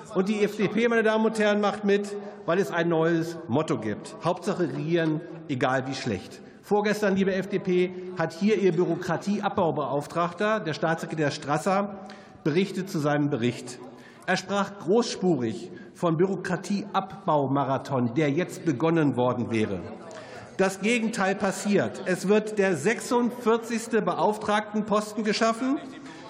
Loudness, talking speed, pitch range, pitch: -26 LUFS, 120 wpm, 165-205 Hz, 190 Hz